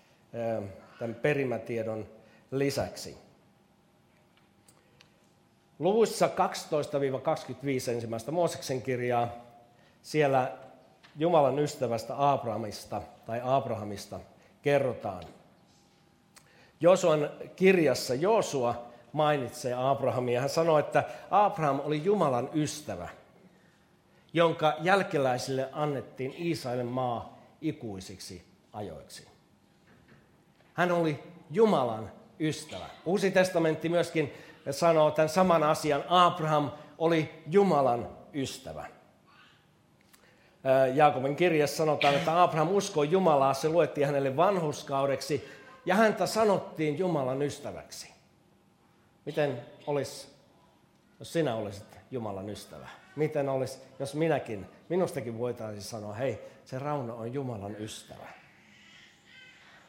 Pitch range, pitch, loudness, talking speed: 125-160 Hz, 140 Hz, -29 LUFS, 85 wpm